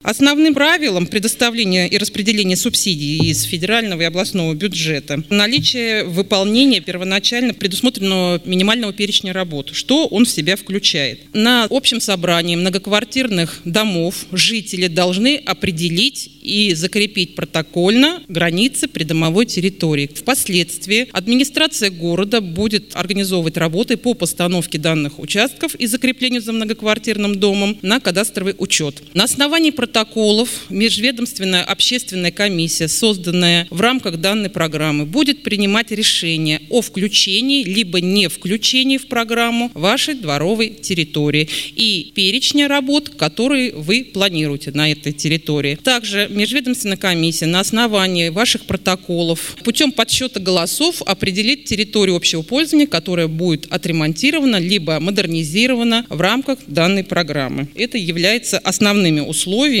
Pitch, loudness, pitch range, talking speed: 195 Hz, -16 LUFS, 175-235 Hz, 115 wpm